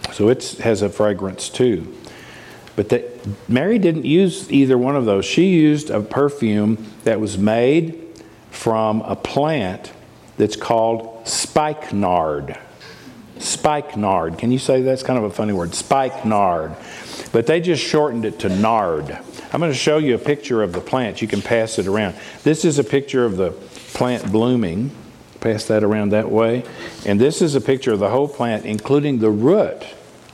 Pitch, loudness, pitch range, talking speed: 115 Hz, -18 LUFS, 105-145 Hz, 170 wpm